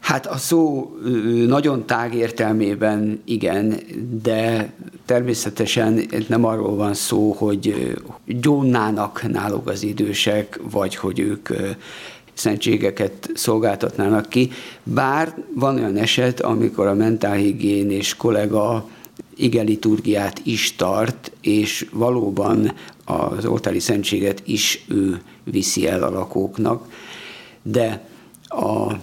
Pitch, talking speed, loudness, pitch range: 110 Hz, 100 wpm, -20 LUFS, 105-120 Hz